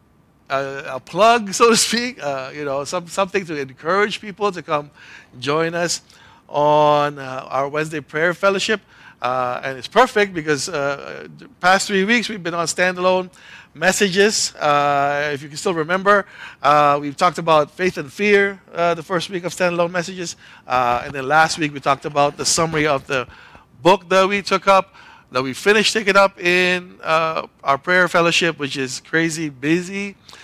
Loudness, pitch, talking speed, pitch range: -18 LUFS, 170 Hz, 175 wpm, 145-190 Hz